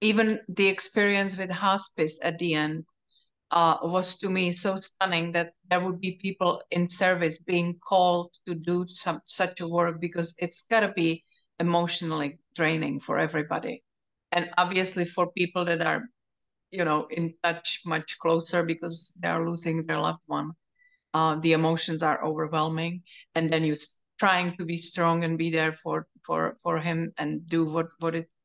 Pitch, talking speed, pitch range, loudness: 170 Hz, 170 wpm, 165-180 Hz, -27 LUFS